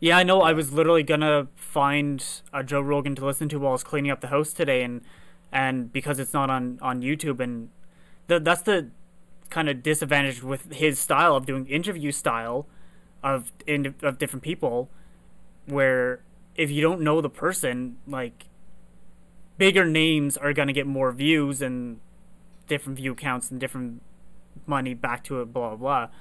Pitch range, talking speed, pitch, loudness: 130-160 Hz, 175 wpm, 140 Hz, -23 LUFS